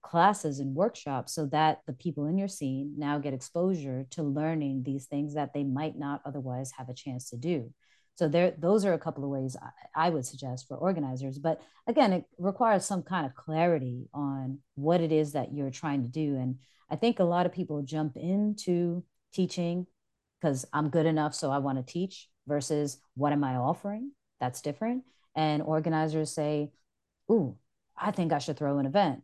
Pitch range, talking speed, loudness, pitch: 140-175 Hz, 195 wpm, -31 LUFS, 150 Hz